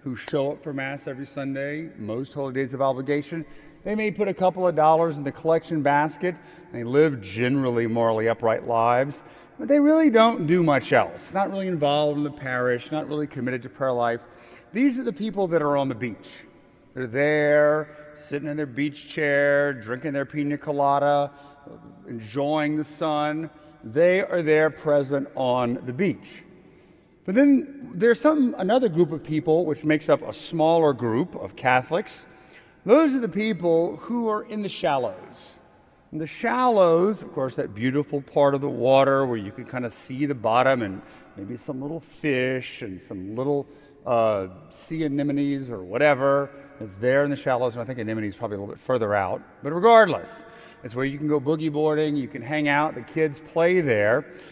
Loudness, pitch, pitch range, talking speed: -23 LUFS, 145 Hz, 130-160 Hz, 185 wpm